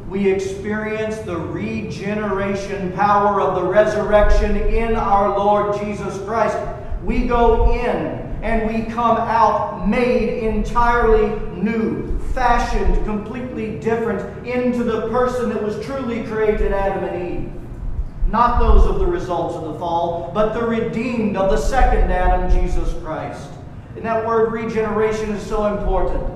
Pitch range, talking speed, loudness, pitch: 195-225 Hz, 135 wpm, -20 LUFS, 215 Hz